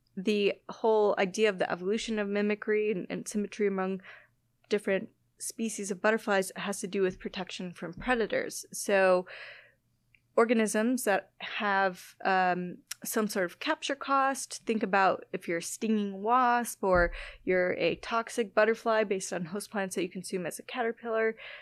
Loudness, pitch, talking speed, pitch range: -30 LUFS, 205 Hz, 155 wpm, 190-225 Hz